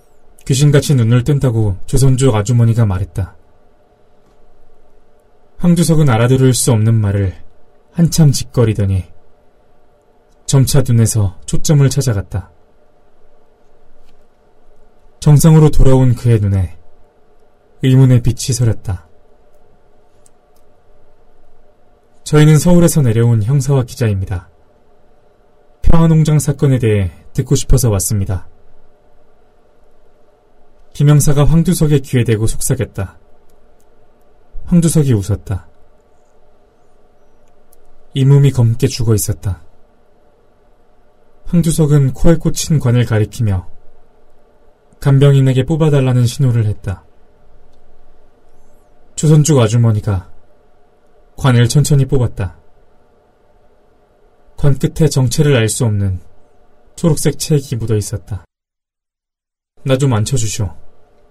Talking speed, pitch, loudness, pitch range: 205 characters per minute, 130 Hz, -13 LUFS, 105-145 Hz